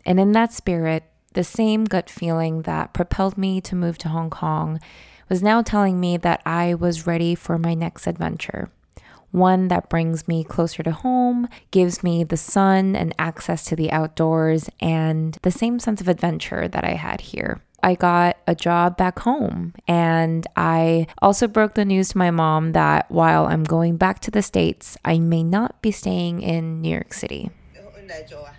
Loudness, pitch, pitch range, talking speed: -20 LUFS, 170 Hz, 165-190 Hz, 180 wpm